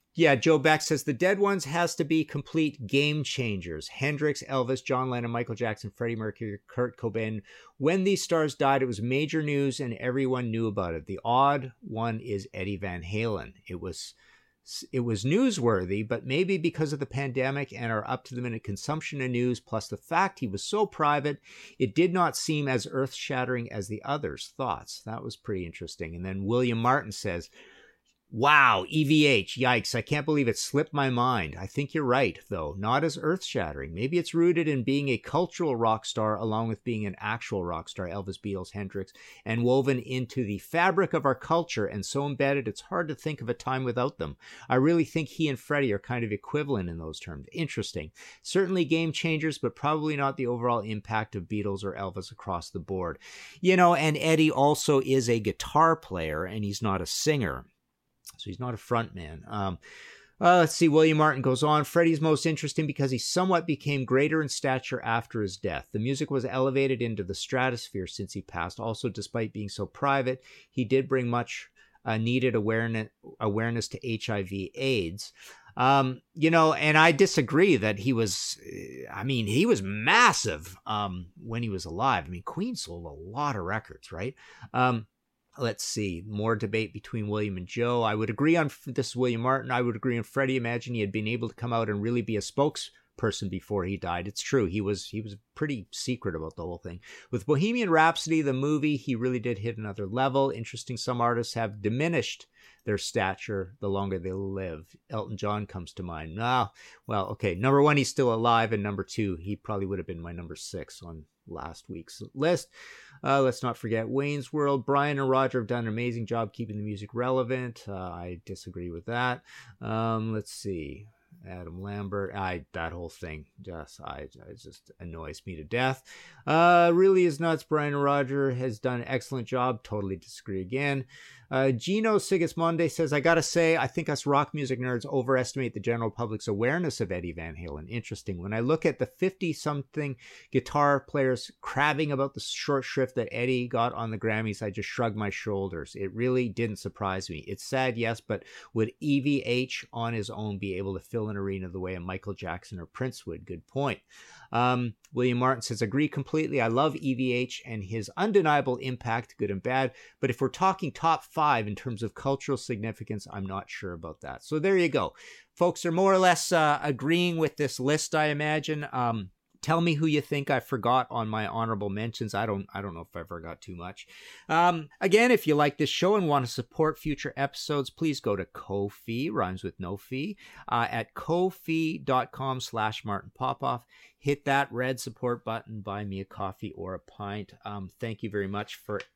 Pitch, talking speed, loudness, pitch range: 125 Hz, 195 wpm, -28 LUFS, 105-145 Hz